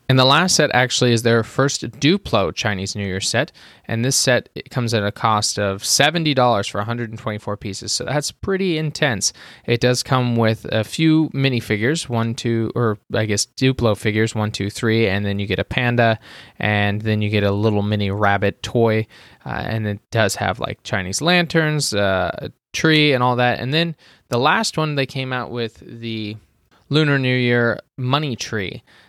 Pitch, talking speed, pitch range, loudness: 115 Hz, 190 wpm, 105-135 Hz, -19 LUFS